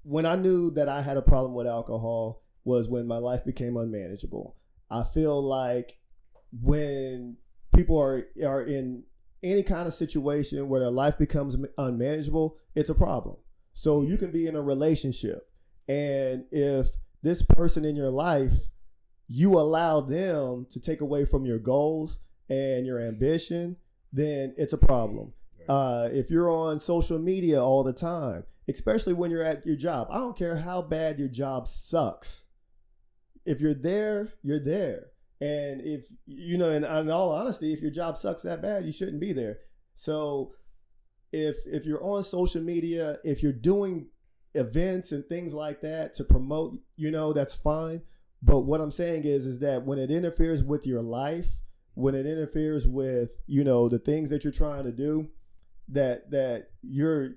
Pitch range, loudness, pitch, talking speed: 130-160 Hz, -28 LUFS, 145 Hz, 170 wpm